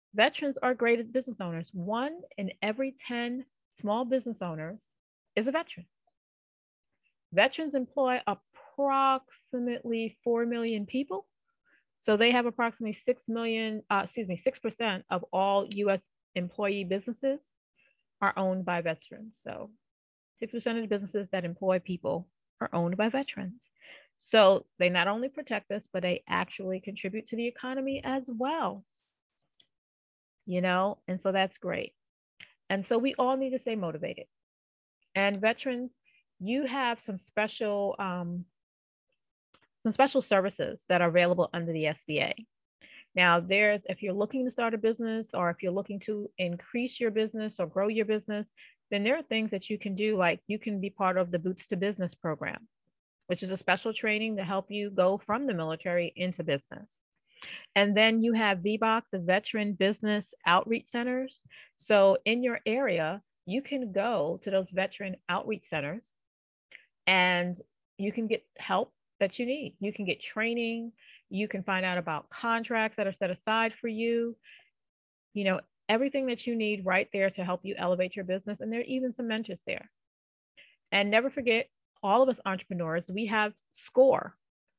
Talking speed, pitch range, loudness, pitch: 160 wpm, 190-235 Hz, -30 LUFS, 210 Hz